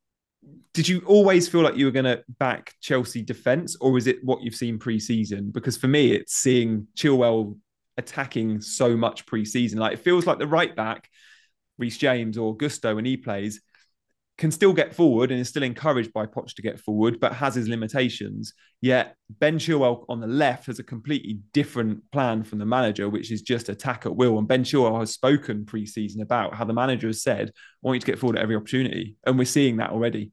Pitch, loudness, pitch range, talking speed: 120 Hz, -24 LUFS, 110-130 Hz, 215 wpm